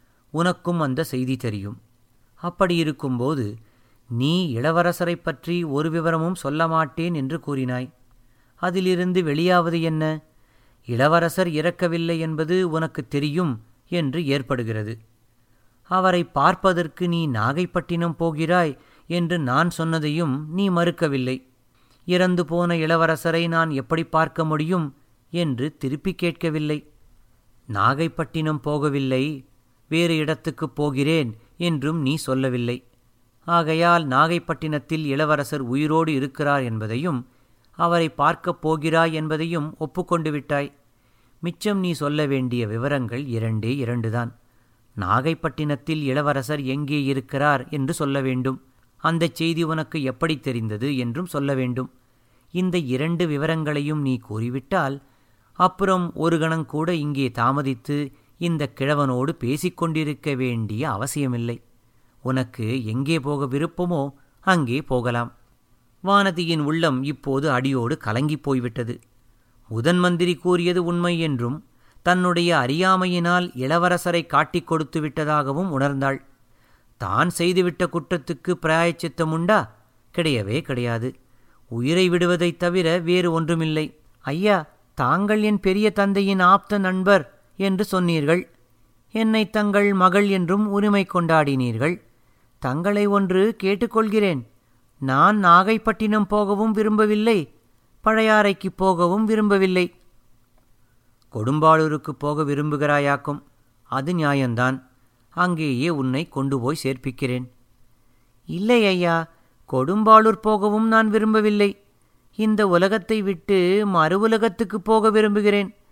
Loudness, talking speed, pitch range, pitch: -22 LUFS, 95 wpm, 130-175 Hz, 155 Hz